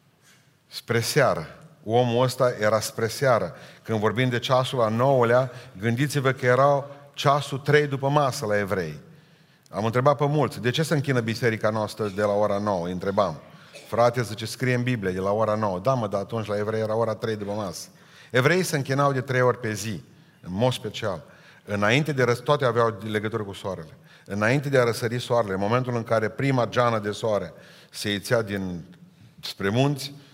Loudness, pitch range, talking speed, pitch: -24 LUFS, 105-135 Hz, 190 wpm, 120 Hz